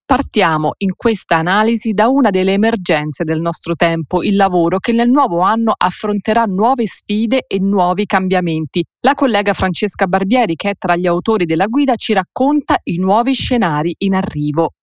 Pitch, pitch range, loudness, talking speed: 195 Hz, 175-230 Hz, -14 LUFS, 165 wpm